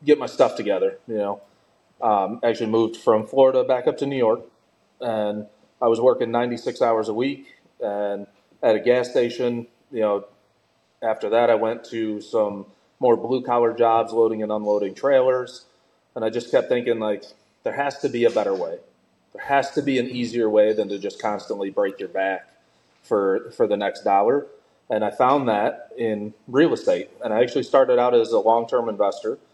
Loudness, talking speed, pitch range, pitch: -22 LUFS, 190 wpm, 105-140 Hz, 120 Hz